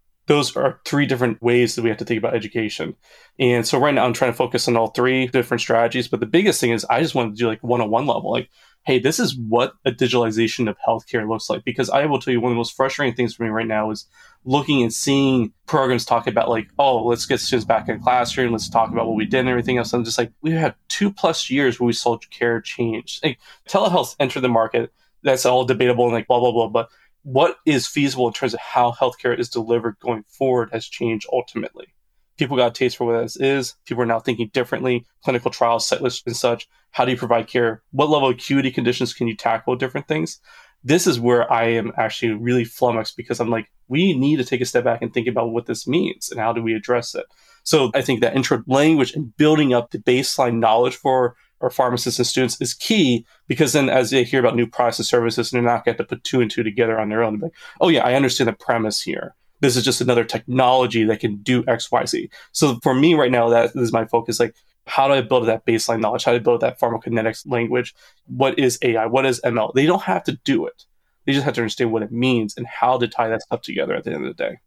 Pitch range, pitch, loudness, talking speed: 115-130 Hz, 120 Hz, -20 LUFS, 250 wpm